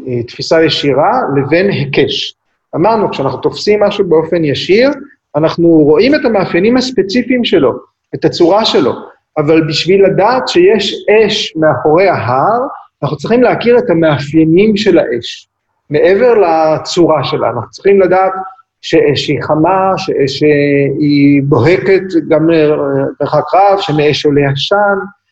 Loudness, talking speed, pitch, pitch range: -10 LUFS, 125 wpm, 165 Hz, 150-200 Hz